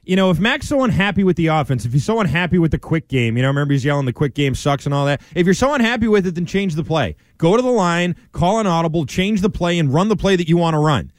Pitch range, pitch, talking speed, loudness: 145-190 Hz, 170 Hz, 310 wpm, -17 LUFS